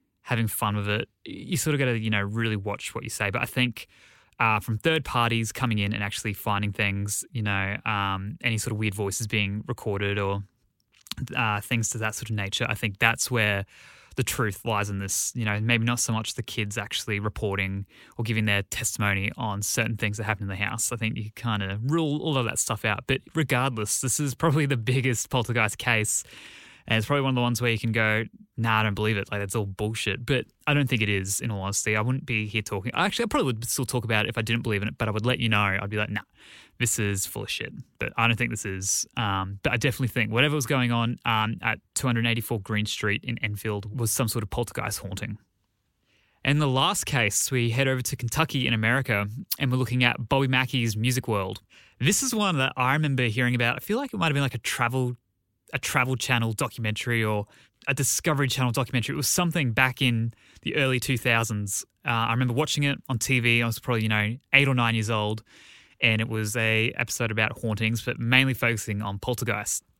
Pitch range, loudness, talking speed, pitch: 105-125 Hz, -26 LUFS, 235 wpm, 115 Hz